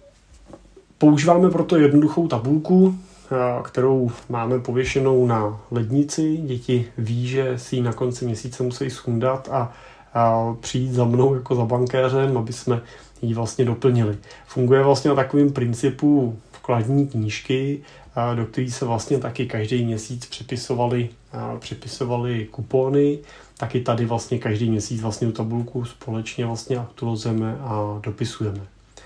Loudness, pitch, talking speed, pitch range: -22 LUFS, 125 Hz, 125 wpm, 115-135 Hz